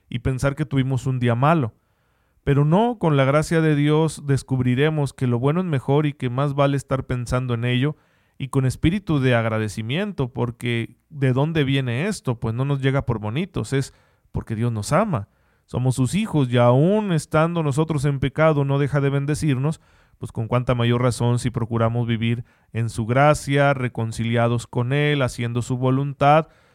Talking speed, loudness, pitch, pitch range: 175 wpm, -21 LUFS, 135 Hz, 120-150 Hz